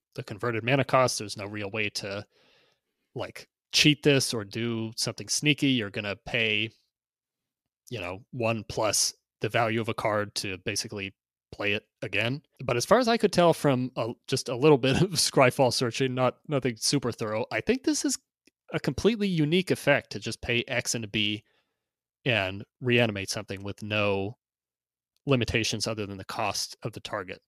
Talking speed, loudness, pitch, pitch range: 180 wpm, -27 LUFS, 120 Hz, 105-135 Hz